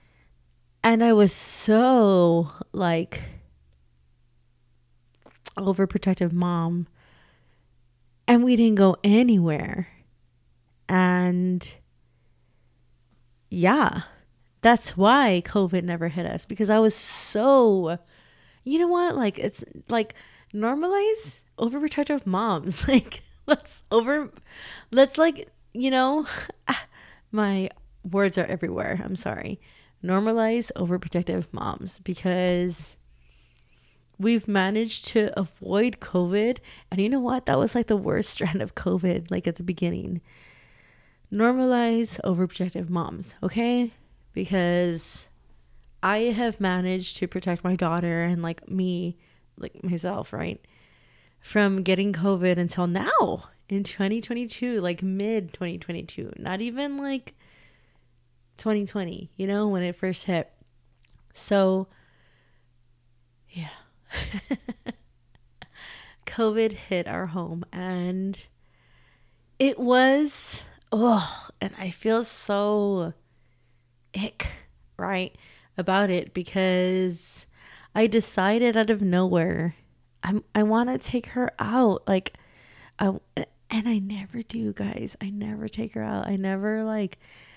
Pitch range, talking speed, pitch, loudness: 170-220 Hz, 105 wpm, 190 Hz, -25 LUFS